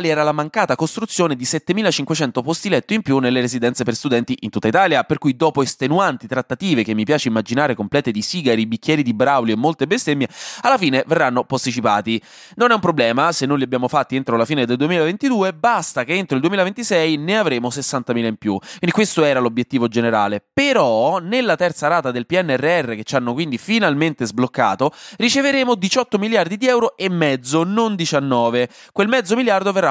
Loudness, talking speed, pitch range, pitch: -18 LUFS, 185 wpm, 125-190 Hz, 150 Hz